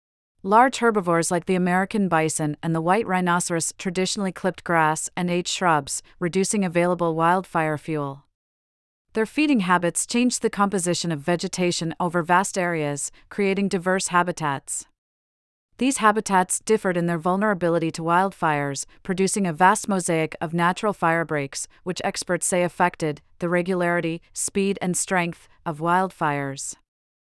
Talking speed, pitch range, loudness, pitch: 130 wpm, 165-190 Hz, -23 LUFS, 175 Hz